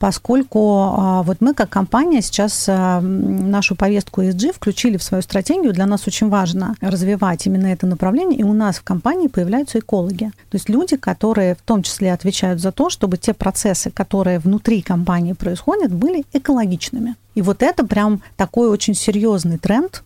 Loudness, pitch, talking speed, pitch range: -17 LUFS, 200 Hz, 165 wpm, 190-230 Hz